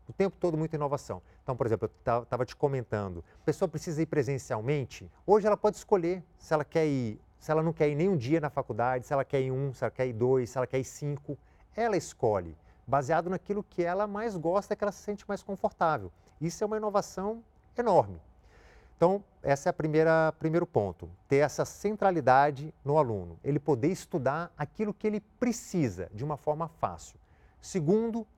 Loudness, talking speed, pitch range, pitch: -30 LUFS, 200 wpm, 130-185 Hz, 155 Hz